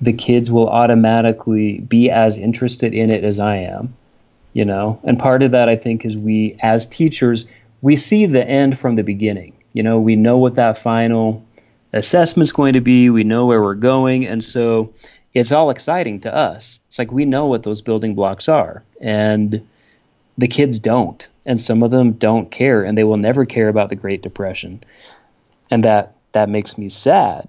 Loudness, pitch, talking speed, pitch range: -15 LUFS, 115 Hz, 195 wpm, 110-125 Hz